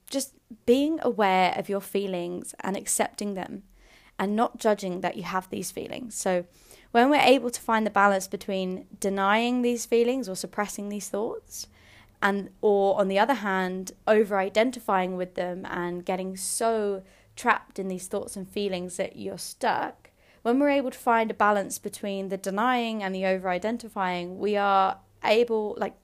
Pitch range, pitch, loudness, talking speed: 190-230 Hz, 200 Hz, -26 LUFS, 165 wpm